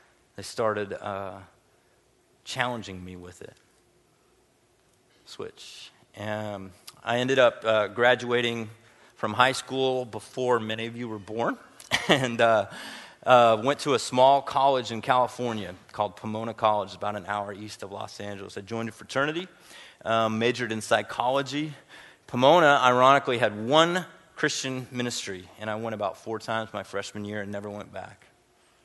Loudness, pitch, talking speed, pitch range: -25 LUFS, 115 Hz, 150 wpm, 105-125 Hz